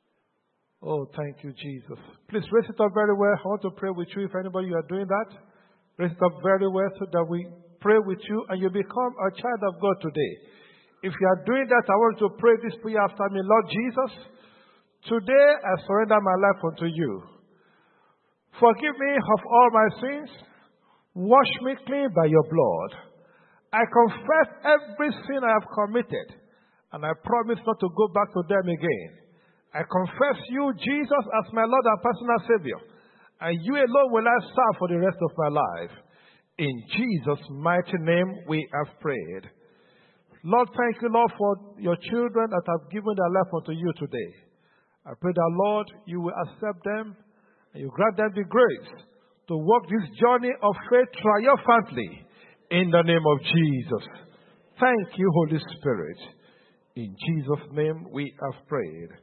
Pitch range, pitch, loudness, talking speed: 175-235 Hz, 200 Hz, -24 LUFS, 175 wpm